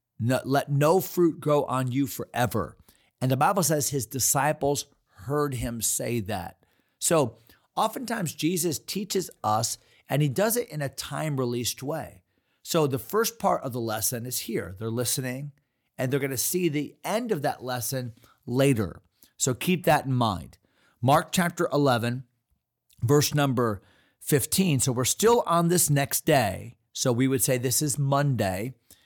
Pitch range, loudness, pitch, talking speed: 120-150 Hz, -26 LUFS, 135 Hz, 165 wpm